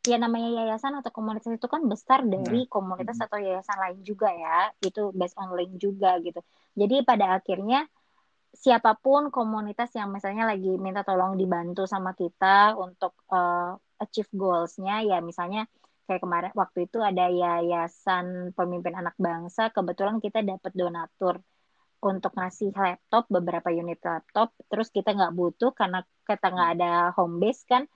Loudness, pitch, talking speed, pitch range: -27 LUFS, 195 Hz, 150 wpm, 180-220 Hz